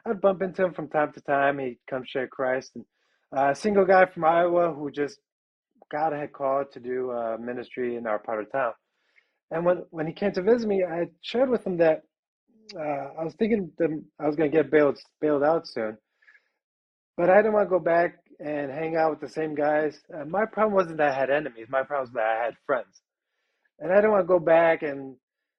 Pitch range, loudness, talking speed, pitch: 135-185 Hz, -25 LUFS, 225 wpm, 155 Hz